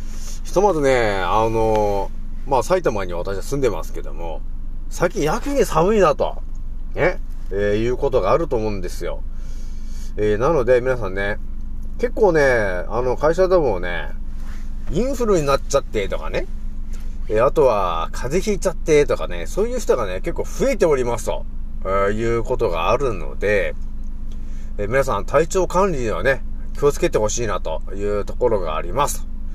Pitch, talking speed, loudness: 105 Hz, 320 characters per minute, -20 LUFS